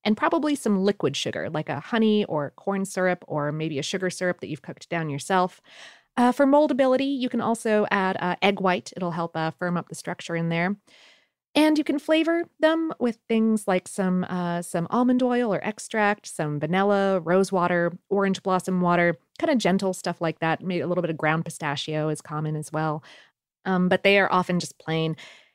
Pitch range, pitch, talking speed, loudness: 165-215 Hz, 185 Hz, 200 wpm, -24 LUFS